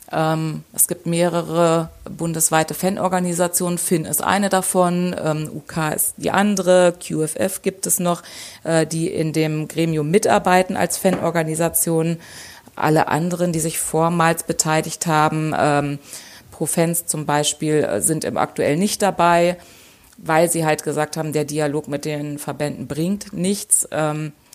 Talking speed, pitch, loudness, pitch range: 120 wpm, 165 Hz, -19 LUFS, 155-180 Hz